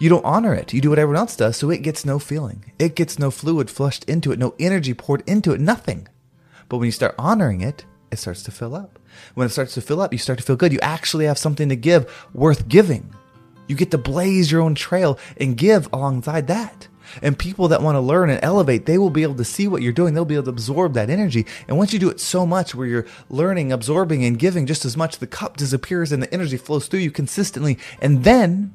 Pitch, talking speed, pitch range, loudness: 150 Hz, 255 wpm, 130-175 Hz, -19 LUFS